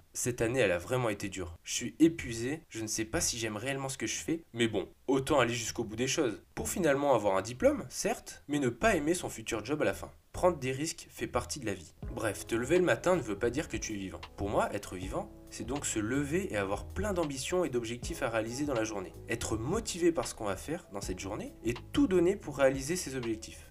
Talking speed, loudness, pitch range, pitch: 260 wpm, -33 LUFS, 105-160 Hz, 120 Hz